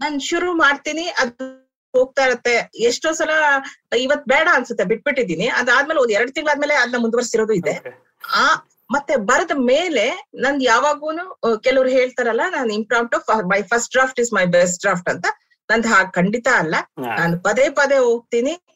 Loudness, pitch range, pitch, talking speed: -18 LUFS, 230-295 Hz, 260 Hz, 145 wpm